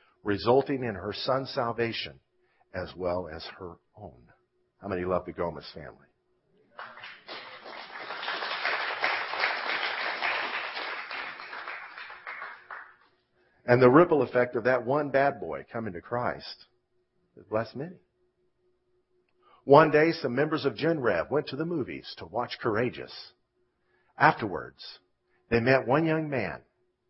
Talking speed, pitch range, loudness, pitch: 110 wpm, 110-155 Hz, -27 LUFS, 130 Hz